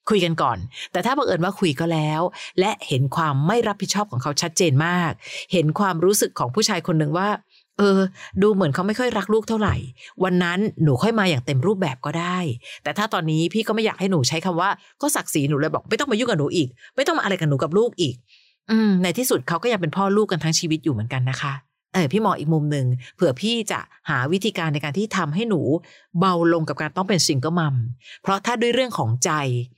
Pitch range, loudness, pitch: 155-205 Hz, -21 LUFS, 175 Hz